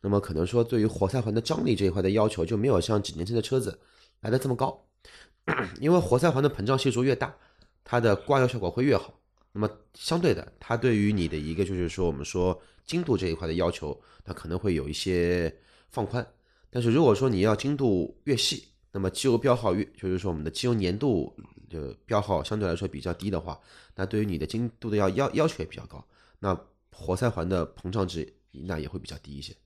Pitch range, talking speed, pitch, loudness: 90-120 Hz, 330 characters per minute, 100 Hz, -27 LUFS